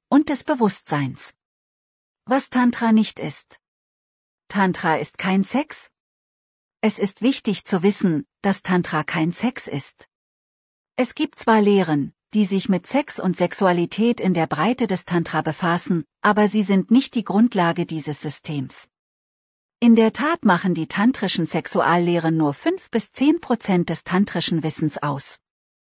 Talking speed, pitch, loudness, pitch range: 140 wpm, 185 Hz, -21 LUFS, 160-225 Hz